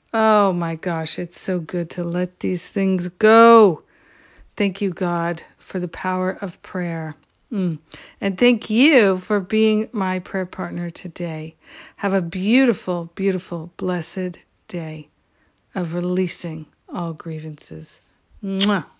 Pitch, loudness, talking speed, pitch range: 180 Hz, -20 LUFS, 125 wpm, 170-195 Hz